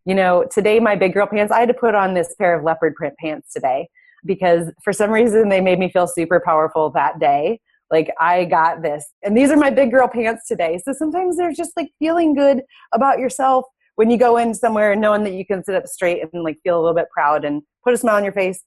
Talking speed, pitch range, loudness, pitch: 250 wpm, 175-250 Hz, -17 LUFS, 205 Hz